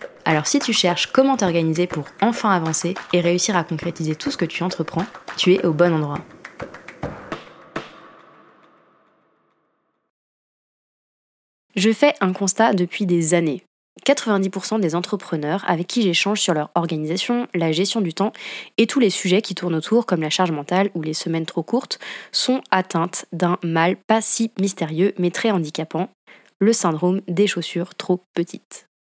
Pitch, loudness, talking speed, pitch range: 180 Hz, -20 LUFS, 155 wpm, 170-205 Hz